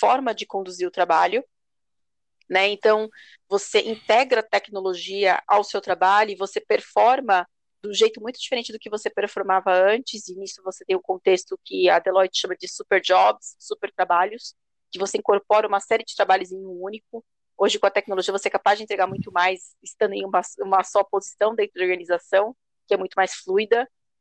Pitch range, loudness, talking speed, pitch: 190-220 Hz, -22 LUFS, 195 wpm, 200 Hz